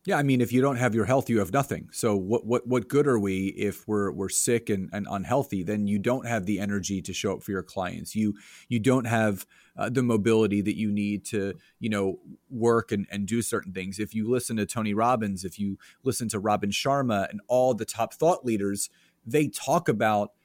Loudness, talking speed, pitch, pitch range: -27 LUFS, 230 wpm, 110 Hz, 100-125 Hz